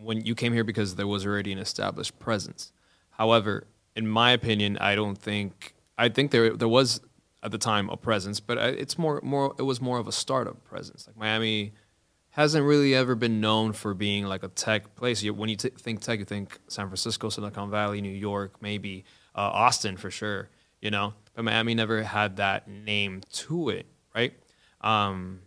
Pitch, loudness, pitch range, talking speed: 110 Hz, -27 LUFS, 100-115 Hz, 190 wpm